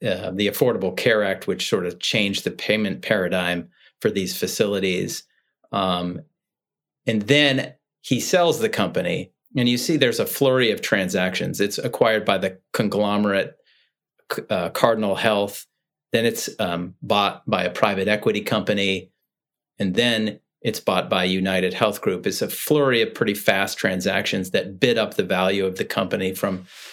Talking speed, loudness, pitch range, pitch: 160 wpm, -22 LUFS, 95-110 Hz, 100 Hz